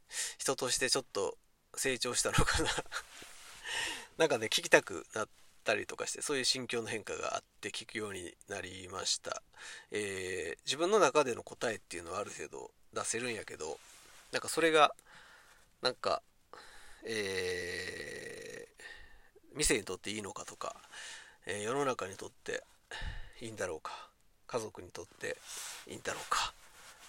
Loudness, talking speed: -35 LUFS, 290 characters per minute